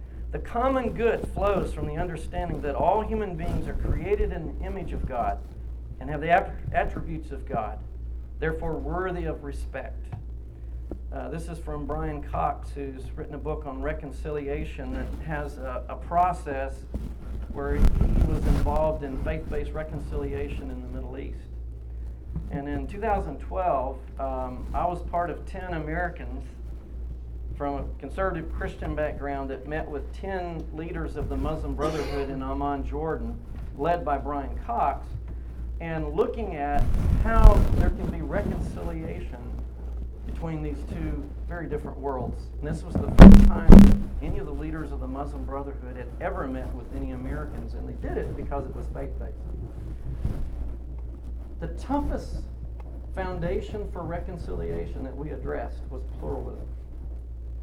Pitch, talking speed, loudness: 65 Hz, 145 wpm, -27 LUFS